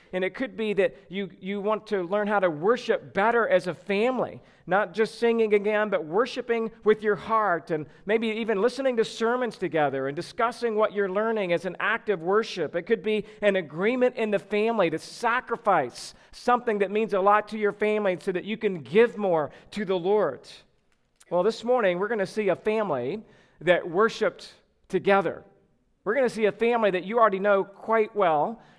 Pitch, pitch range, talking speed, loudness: 210 Hz, 190-225 Hz, 195 wpm, -25 LUFS